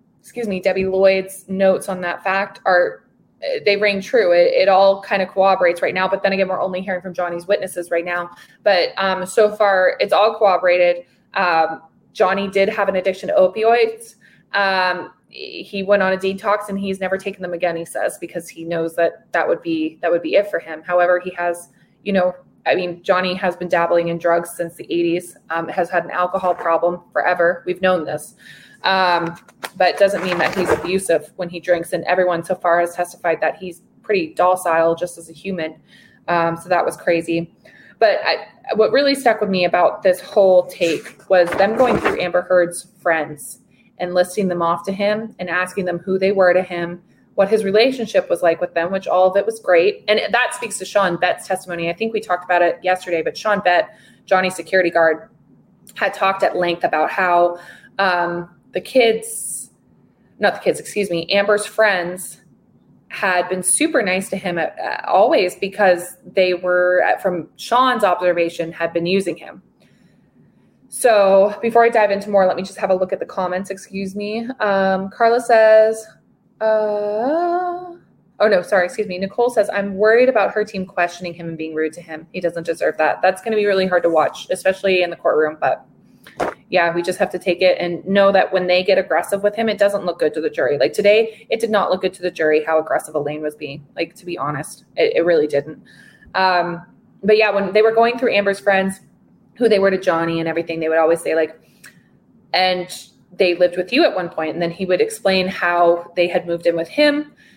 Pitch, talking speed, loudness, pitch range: 185 Hz, 205 wpm, -18 LUFS, 175-205 Hz